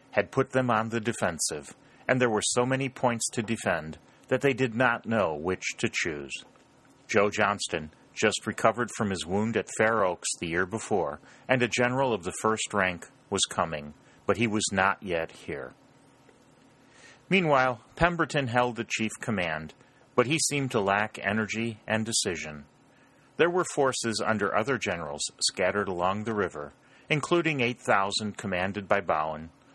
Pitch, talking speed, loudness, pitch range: 110 Hz, 160 wpm, -28 LUFS, 100-130 Hz